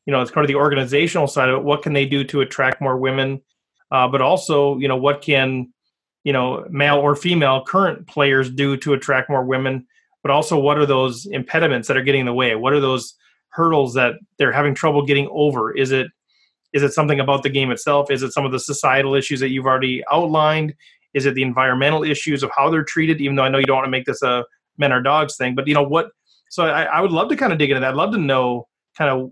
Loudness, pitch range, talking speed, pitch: -18 LUFS, 130-150 Hz, 255 wpm, 140 Hz